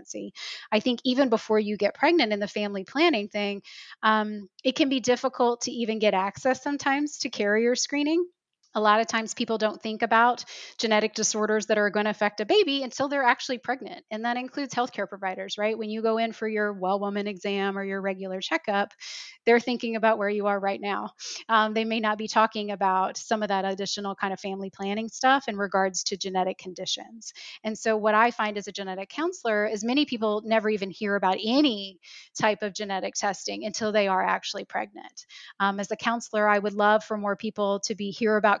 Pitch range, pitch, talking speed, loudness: 200-235 Hz, 215 Hz, 210 wpm, -26 LUFS